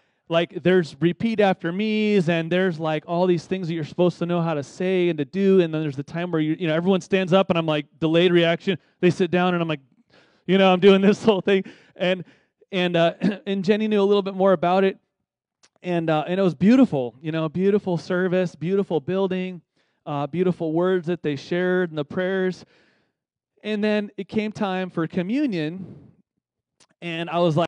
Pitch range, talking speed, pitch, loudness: 165-195 Hz, 210 wpm, 180 Hz, -22 LUFS